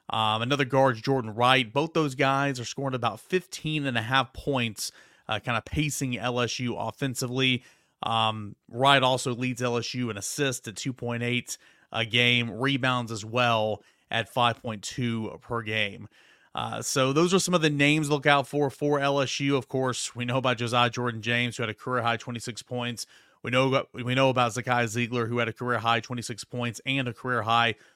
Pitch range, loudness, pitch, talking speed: 115-135 Hz, -26 LUFS, 125 Hz, 190 wpm